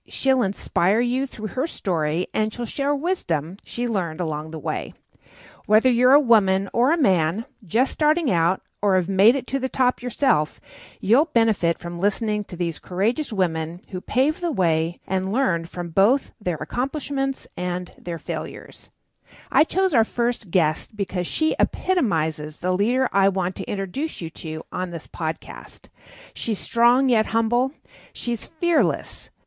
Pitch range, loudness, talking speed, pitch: 175-255 Hz, -23 LUFS, 160 wpm, 210 Hz